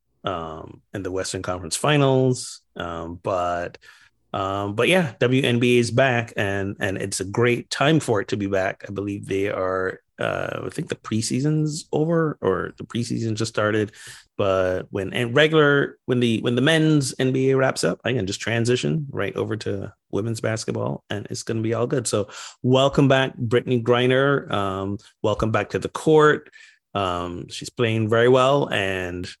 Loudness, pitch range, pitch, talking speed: -22 LUFS, 95-130 Hz, 115 Hz, 170 wpm